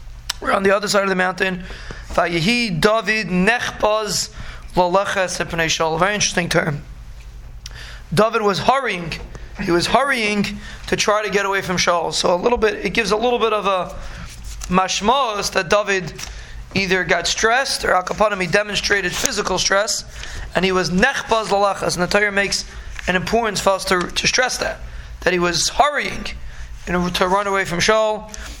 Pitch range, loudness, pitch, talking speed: 175-210 Hz, -18 LUFS, 190 Hz, 145 wpm